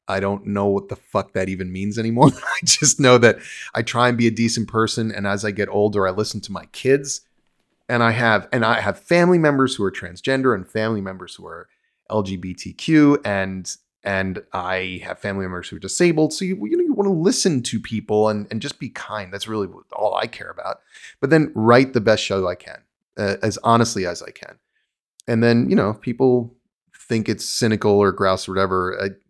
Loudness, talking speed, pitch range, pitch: -20 LUFS, 215 wpm, 100-125 Hz, 110 Hz